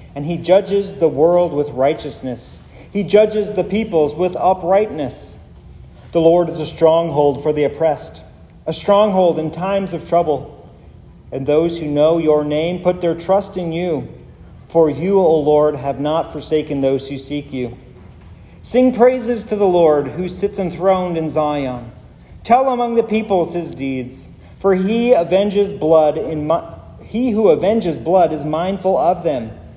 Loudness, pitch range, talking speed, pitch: -17 LUFS, 145-190 Hz, 160 wpm, 165 Hz